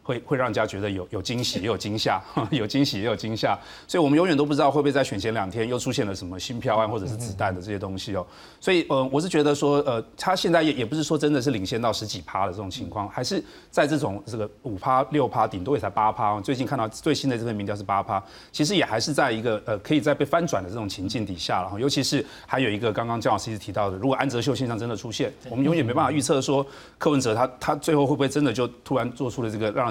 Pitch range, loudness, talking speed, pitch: 105-145 Hz, -25 LUFS, 415 characters per minute, 125 Hz